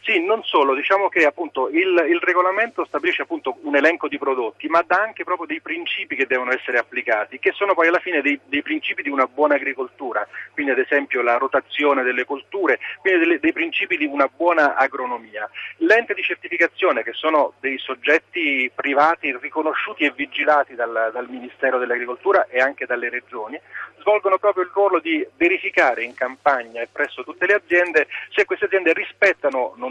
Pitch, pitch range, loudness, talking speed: 165 Hz, 140-210 Hz, -20 LUFS, 180 wpm